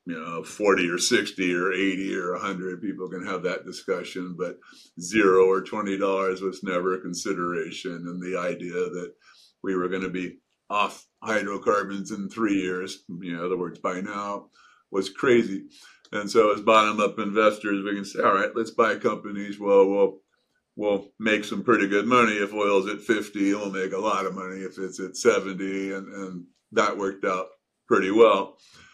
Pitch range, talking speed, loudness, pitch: 95-100 Hz, 180 wpm, -25 LUFS, 95 Hz